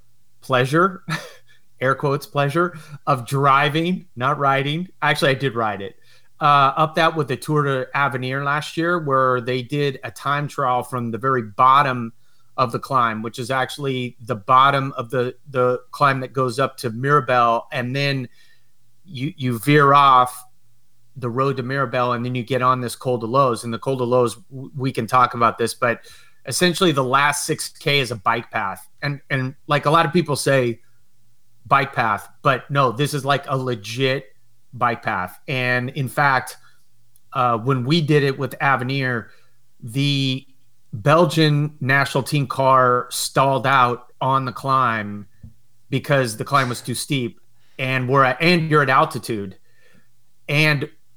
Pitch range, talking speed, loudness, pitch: 120-140 Hz, 165 wpm, -19 LUFS, 130 Hz